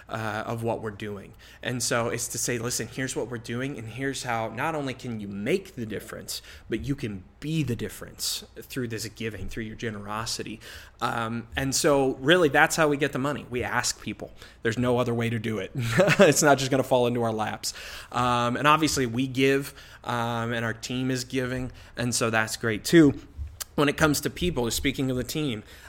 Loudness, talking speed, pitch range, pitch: -26 LUFS, 210 wpm, 115-135 Hz, 120 Hz